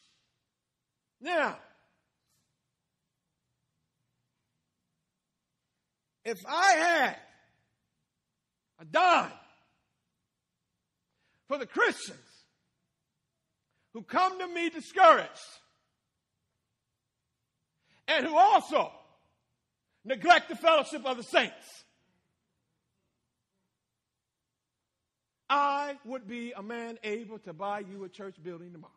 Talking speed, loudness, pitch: 75 wpm, -27 LUFS, 240 Hz